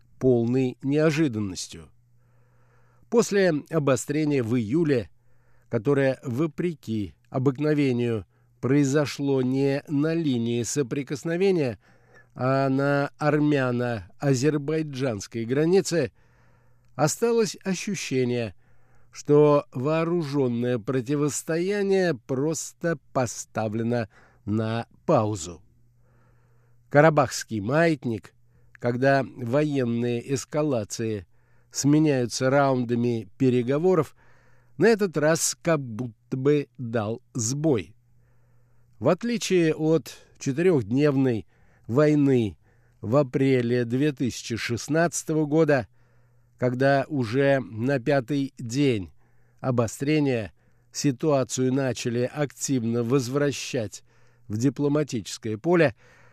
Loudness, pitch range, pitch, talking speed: -25 LUFS, 120-150 Hz, 130 Hz, 70 wpm